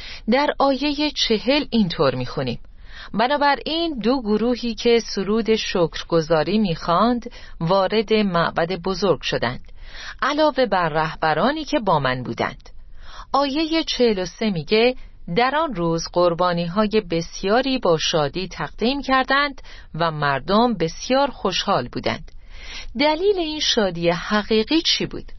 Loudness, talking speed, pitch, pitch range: -20 LUFS, 115 wpm, 220 Hz, 170-265 Hz